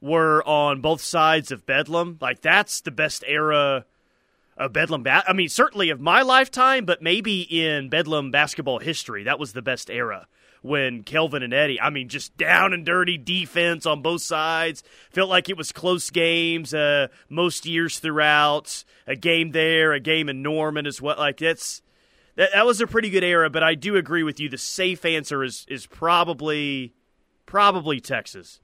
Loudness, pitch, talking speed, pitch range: -21 LUFS, 160 Hz, 180 wpm, 150-175 Hz